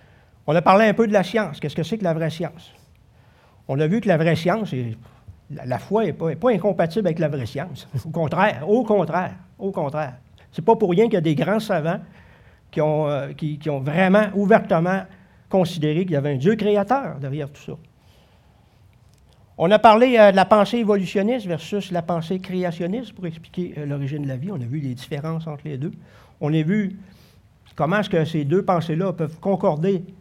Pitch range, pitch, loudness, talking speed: 145-200 Hz, 170 Hz, -21 LUFS, 205 wpm